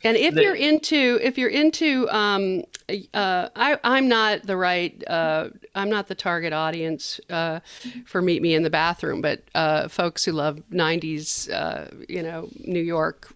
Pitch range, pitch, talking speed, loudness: 165-225 Hz, 180 Hz, 170 wpm, -23 LUFS